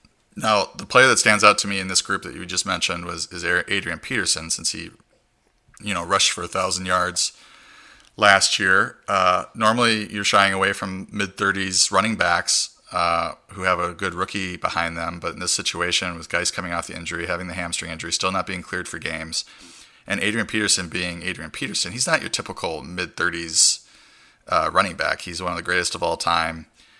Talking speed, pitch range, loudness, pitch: 195 wpm, 85-100 Hz, -21 LUFS, 95 Hz